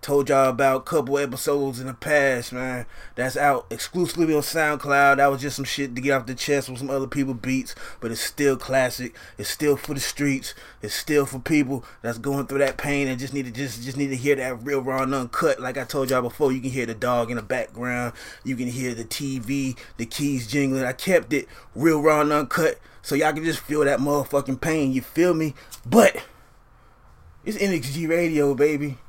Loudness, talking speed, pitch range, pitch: -23 LUFS, 220 wpm, 130-145 Hz, 140 Hz